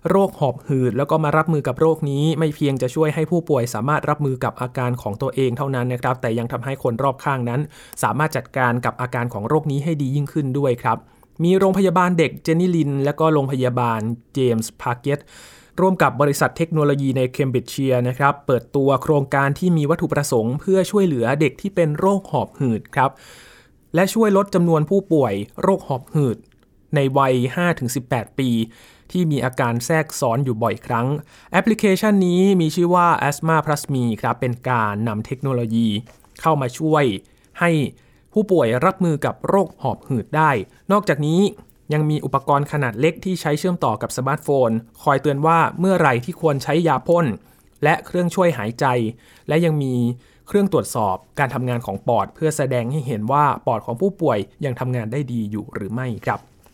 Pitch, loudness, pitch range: 140 Hz, -20 LUFS, 125-160 Hz